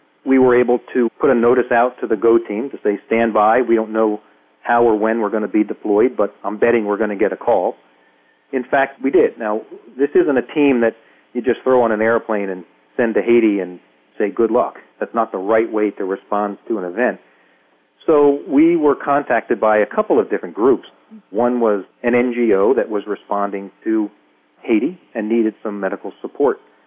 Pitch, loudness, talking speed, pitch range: 110 Hz, -17 LUFS, 210 wpm, 105-120 Hz